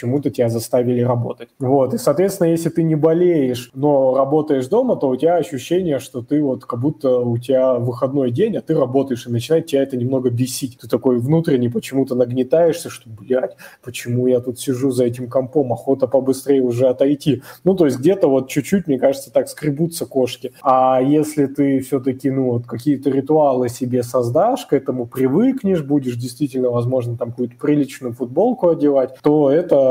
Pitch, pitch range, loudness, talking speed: 135 Hz, 125-145 Hz, -18 LUFS, 175 wpm